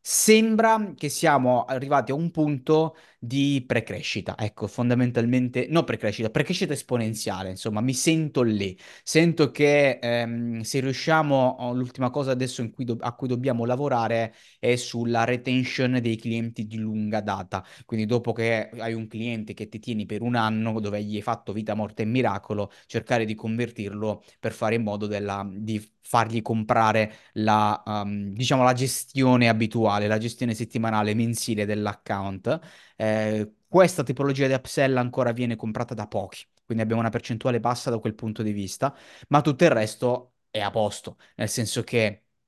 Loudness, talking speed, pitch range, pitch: -25 LUFS, 160 wpm, 110-130 Hz, 115 Hz